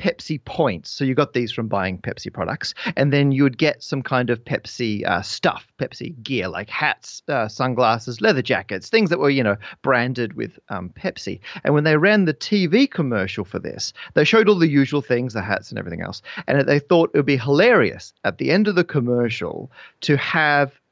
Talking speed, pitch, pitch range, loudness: 210 wpm, 140 Hz, 120-155 Hz, -20 LUFS